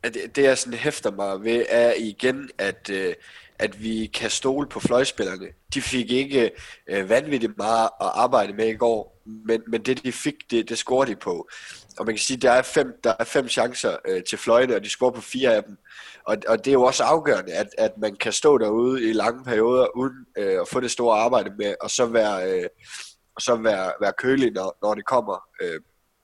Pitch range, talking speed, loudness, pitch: 115-140 Hz, 215 wpm, -23 LUFS, 125 Hz